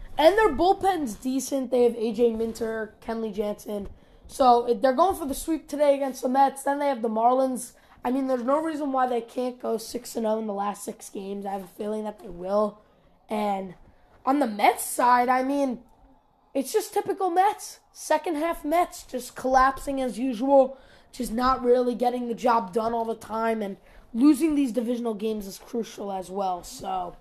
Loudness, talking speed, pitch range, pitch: -25 LUFS, 190 wpm, 220-280 Hz, 245 Hz